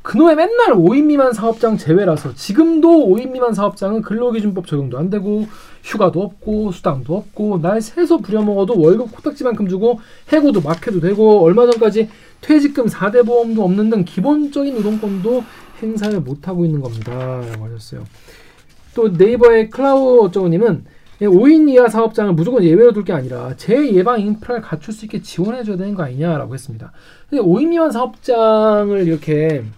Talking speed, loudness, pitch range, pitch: 365 characters per minute, -14 LUFS, 180-240 Hz, 210 Hz